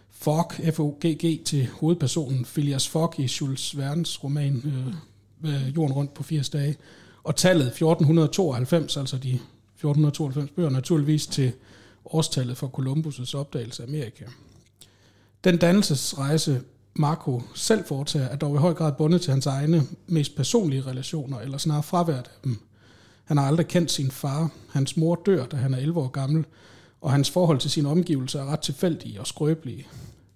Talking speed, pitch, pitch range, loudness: 160 wpm, 145 Hz, 130-160 Hz, -25 LUFS